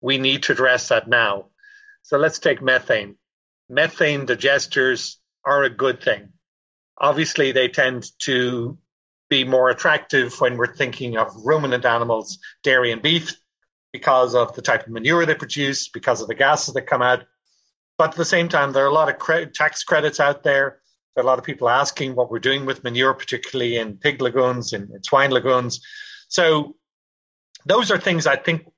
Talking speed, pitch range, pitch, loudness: 180 wpm, 125-155 Hz, 135 Hz, -19 LUFS